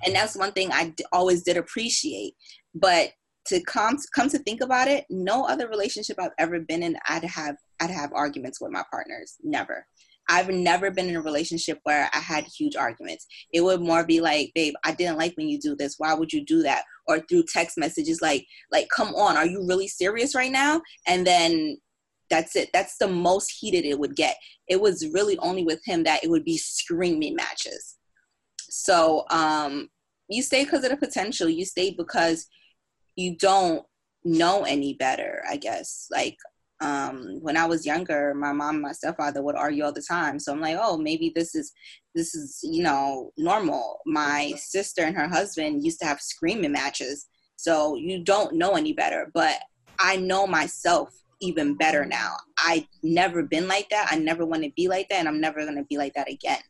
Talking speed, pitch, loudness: 200 wpm, 180 Hz, -25 LUFS